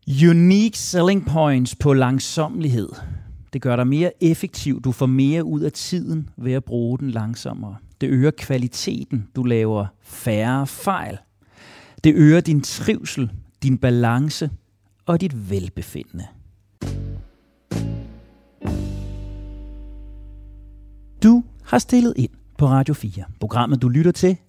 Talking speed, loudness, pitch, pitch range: 120 wpm, -20 LUFS, 125 Hz, 100-150 Hz